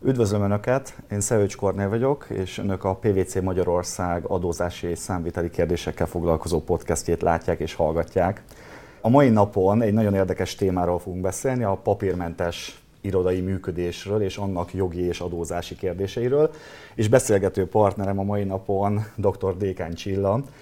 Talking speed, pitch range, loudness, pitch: 140 wpm, 90-105 Hz, -24 LUFS, 95 Hz